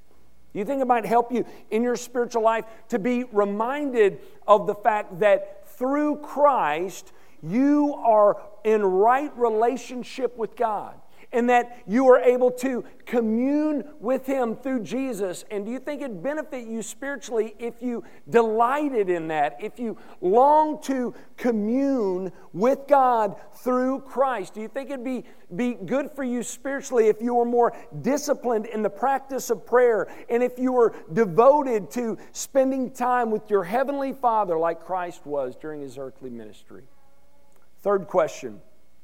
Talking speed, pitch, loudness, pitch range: 155 wpm, 240 Hz, -24 LUFS, 210-265 Hz